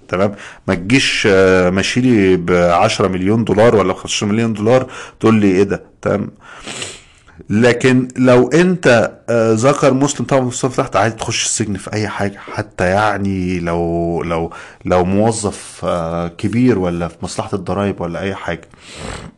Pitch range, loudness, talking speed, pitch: 90-120 Hz, -15 LUFS, 140 wpm, 105 Hz